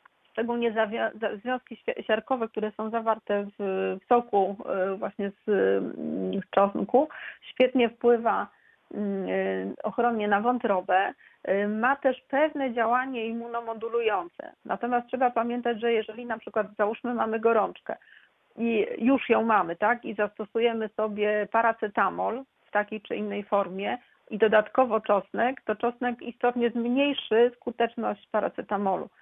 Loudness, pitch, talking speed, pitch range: -27 LUFS, 225 Hz, 110 wpm, 210-240 Hz